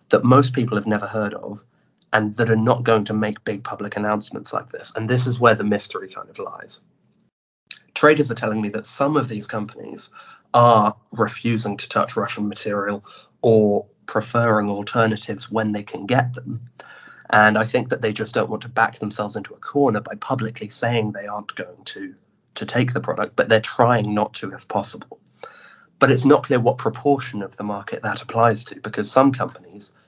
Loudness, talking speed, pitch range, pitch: -21 LUFS, 195 wpm, 105-120 Hz, 110 Hz